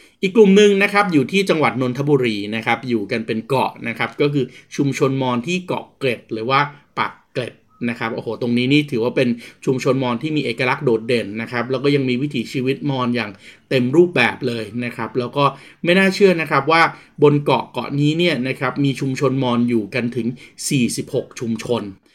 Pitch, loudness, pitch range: 130 Hz, -19 LUFS, 120-145 Hz